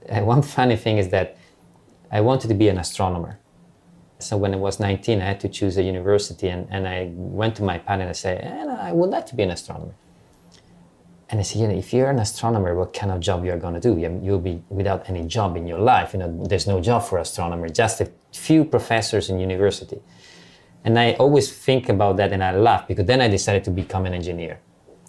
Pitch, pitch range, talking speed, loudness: 100 Hz, 90-110 Hz, 225 wpm, -21 LUFS